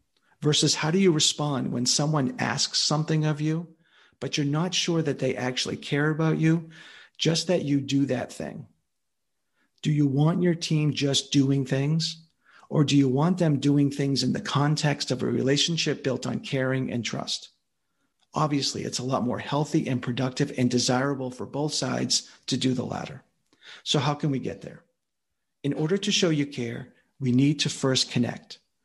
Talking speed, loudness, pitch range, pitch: 180 wpm, -25 LUFS, 130-155 Hz, 145 Hz